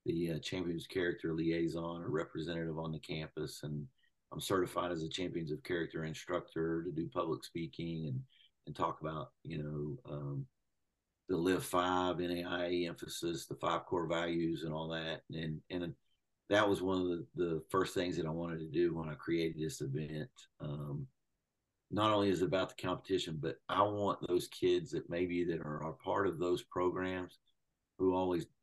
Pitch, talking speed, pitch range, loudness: 85 Hz, 180 wpm, 80-90 Hz, -38 LUFS